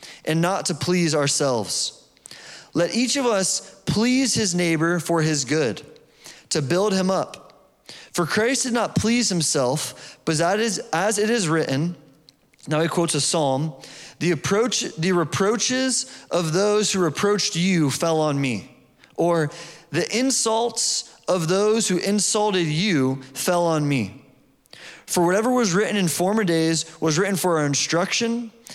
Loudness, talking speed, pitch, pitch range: -21 LUFS, 150 wpm, 175 Hz, 155-210 Hz